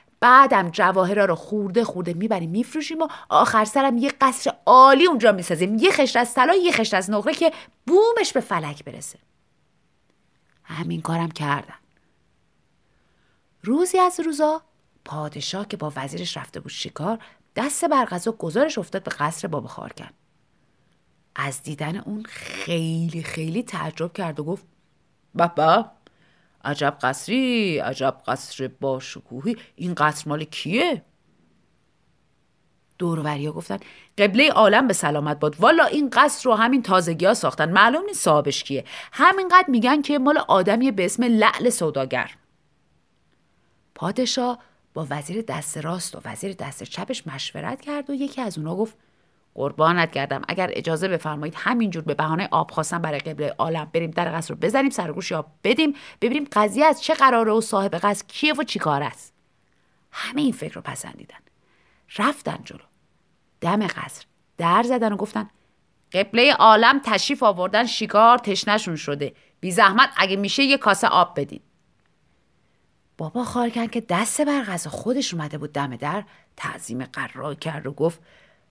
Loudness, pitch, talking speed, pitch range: -21 LUFS, 195 Hz, 145 wpm, 155-250 Hz